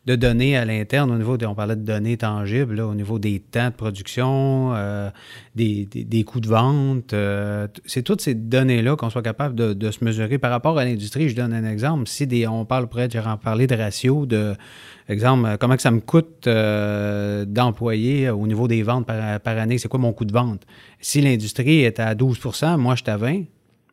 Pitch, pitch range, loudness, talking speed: 120 Hz, 110-130 Hz, -21 LUFS, 220 wpm